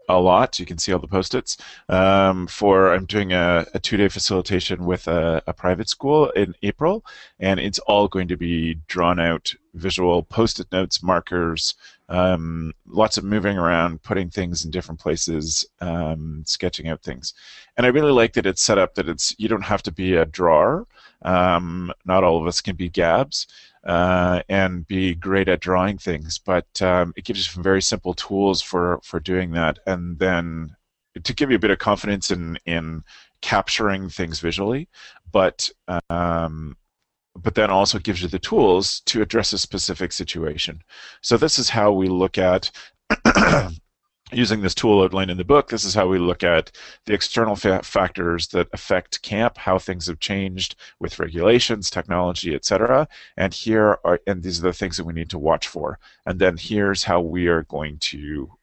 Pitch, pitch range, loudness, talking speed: 90 Hz, 85-100 Hz, -21 LUFS, 185 wpm